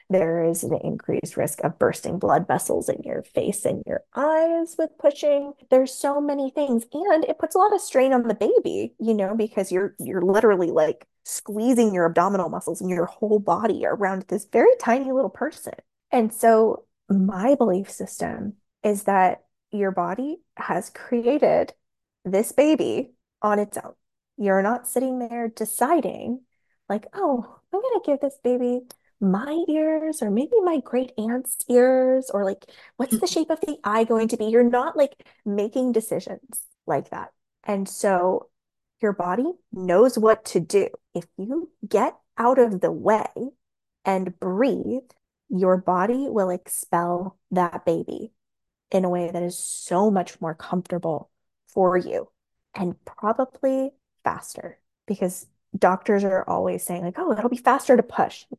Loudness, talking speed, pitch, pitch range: -23 LUFS, 160 wpm, 230 Hz, 190-270 Hz